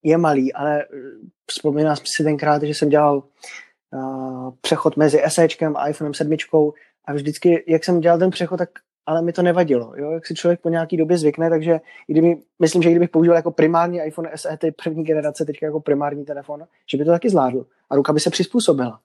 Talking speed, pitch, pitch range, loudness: 200 wpm, 155 Hz, 150-170 Hz, -19 LUFS